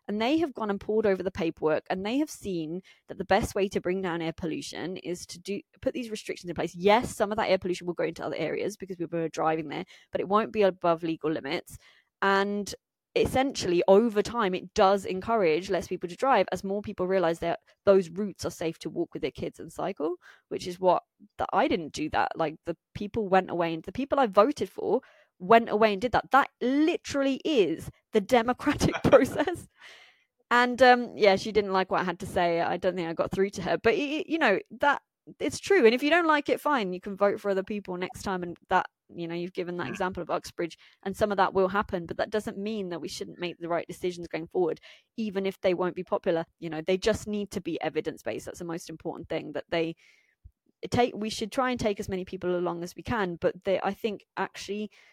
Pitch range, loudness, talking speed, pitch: 175-220 Hz, -28 LUFS, 240 wpm, 195 Hz